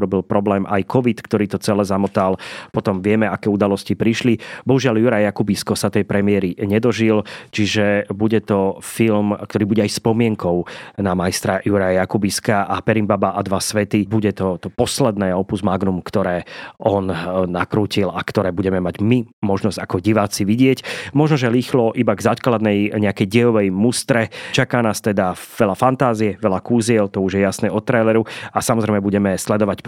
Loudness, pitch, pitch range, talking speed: -18 LUFS, 105 Hz, 100-115 Hz, 165 wpm